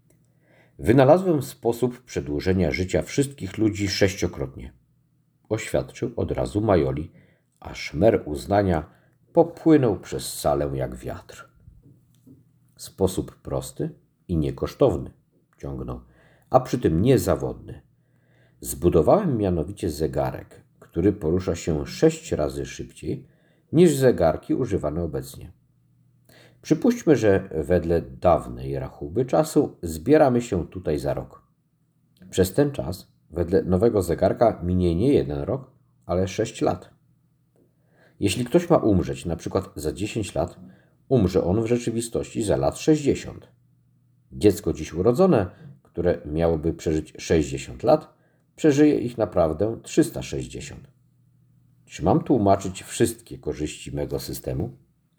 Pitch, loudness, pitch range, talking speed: 95 Hz, -23 LUFS, 80-135 Hz, 110 wpm